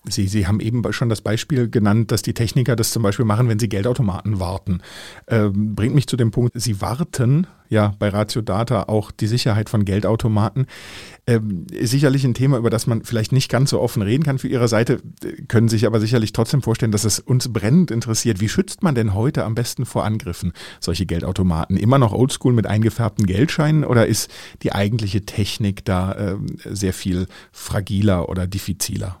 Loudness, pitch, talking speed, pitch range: -19 LUFS, 110 Hz, 195 wpm, 100-125 Hz